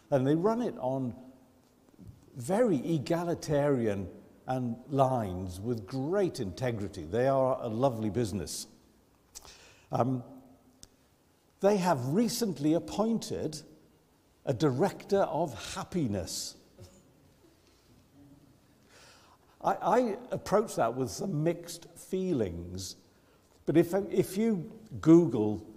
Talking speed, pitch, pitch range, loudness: 90 wpm, 135 Hz, 115-170 Hz, -30 LUFS